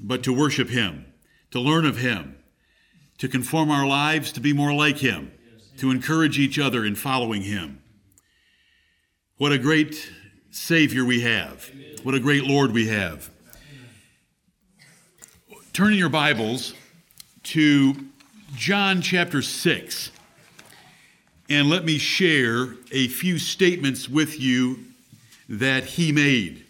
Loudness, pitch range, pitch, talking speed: -22 LUFS, 125-155 Hz, 135 Hz, 125 wpm